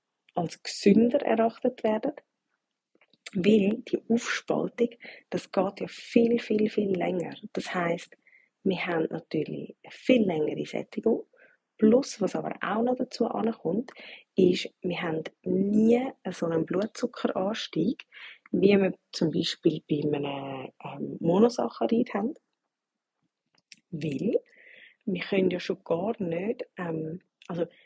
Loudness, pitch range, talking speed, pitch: -28 LUFS, 180-240 Hz, 120 wpm, 215 Hz